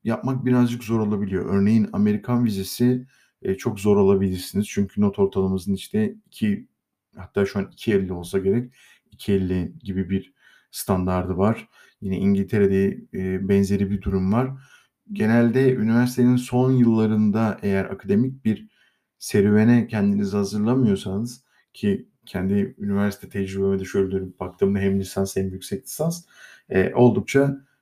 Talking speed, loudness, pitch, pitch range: 125 wpm, -22 LUFS, 100 Hz, 95-120 Hz